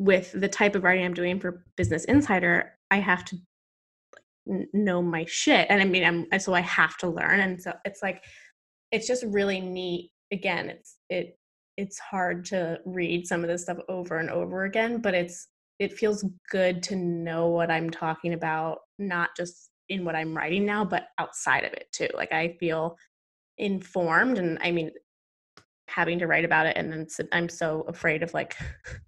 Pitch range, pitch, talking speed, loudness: 170-195 Hz, 180 Hz, 185 wpm, -26 LUFS